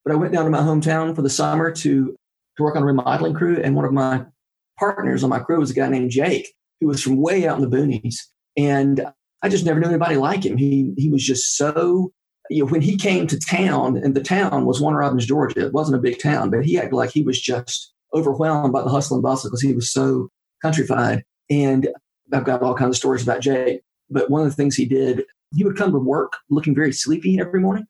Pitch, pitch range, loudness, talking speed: 140 Hz, 130-160 Hz, -20 LUFS, 245 wpm